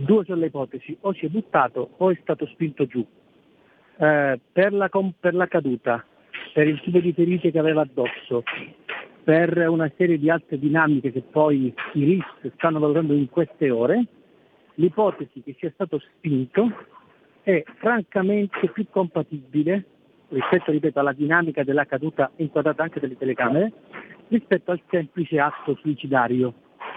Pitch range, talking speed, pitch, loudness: 145-180 Hz, 150 wpm, 160 Hz, -23 LUFS